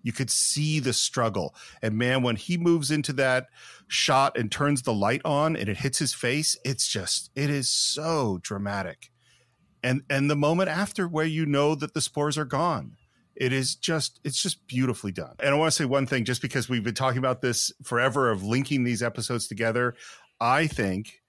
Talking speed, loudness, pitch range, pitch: 200 wpm, -26 LUFS, 120-150 Hz, 135 Hz